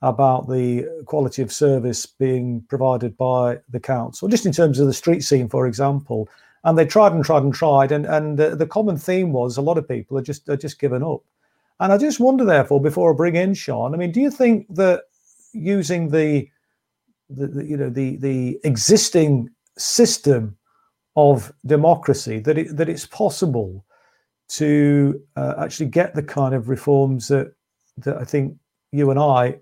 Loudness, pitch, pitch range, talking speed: -19 LUFS, 145 Hz, 130-165 Hz, 185 wpm